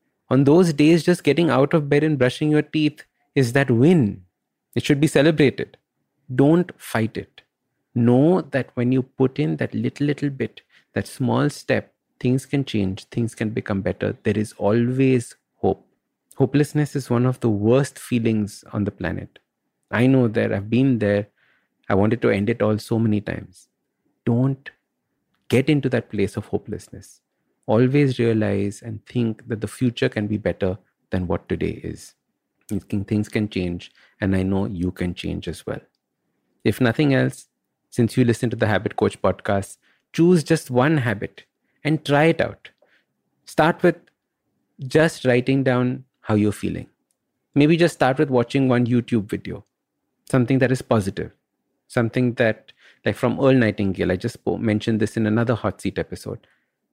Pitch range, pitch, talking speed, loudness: 105-140 Hz, 120 Hz, 165 wpm, -21 LUFS